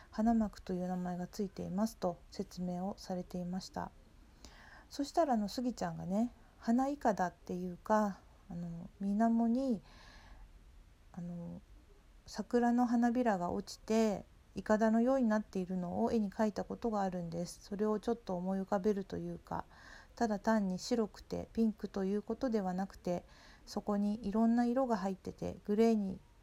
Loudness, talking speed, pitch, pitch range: -36 LUFS, 335 characters per minute, 205 Hz, 180-230 Hz